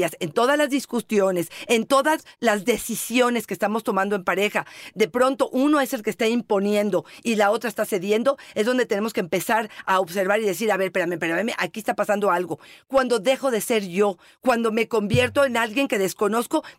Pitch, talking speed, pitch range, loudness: 220 Hz, 195 wpm, 205-250 Hz, -22 LUFS